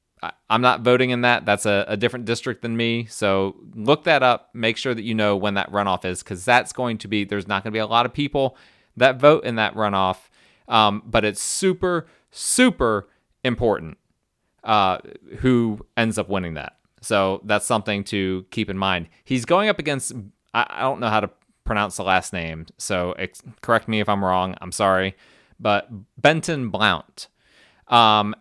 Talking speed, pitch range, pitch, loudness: 190 wpm, 100-120 Hz, 110 Hz, -21 LUFS